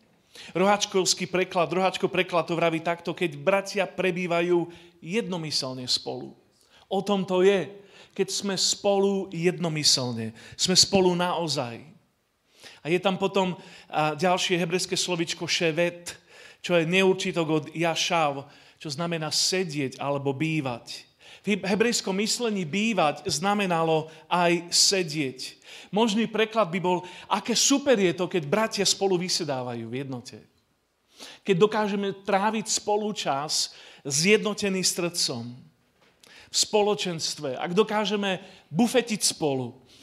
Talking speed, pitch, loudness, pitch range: 115 wpm, 180 Hz, -25 LUFS, 160-195 Hz